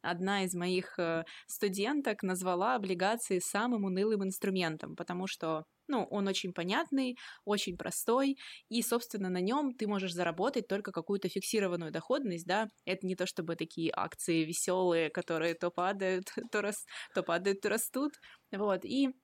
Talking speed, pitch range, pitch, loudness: 145 wpm, 180-220 Hz, 195 Hz, -34 LUFS